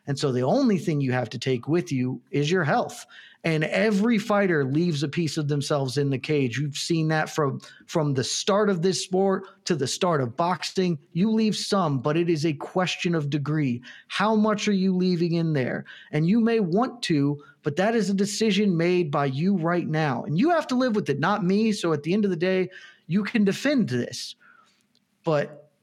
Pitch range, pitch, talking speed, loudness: 150-200 Hz, 175 Hz, 215 wpm, -24 LUFS